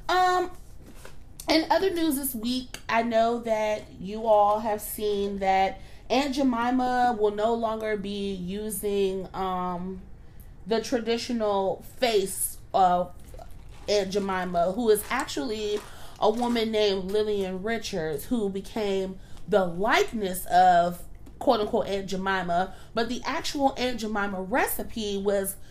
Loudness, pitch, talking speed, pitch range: -26 LUFS, 215 Hz, 120 wpm, 195-240 Hz